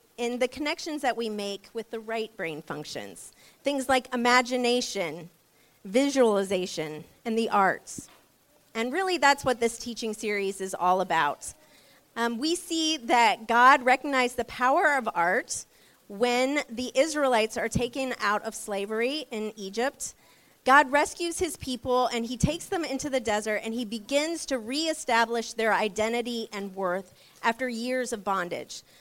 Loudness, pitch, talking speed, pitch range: -27 LUFS, 235 Hz, 150 wpm, 210-265 Hz